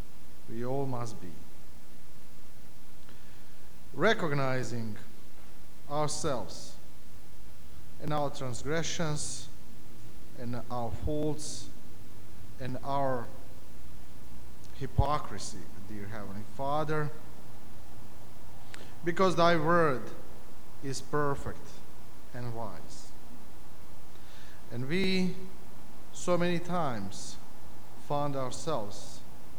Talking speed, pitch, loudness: 65 wpm, 115 Hz, -33 LUFS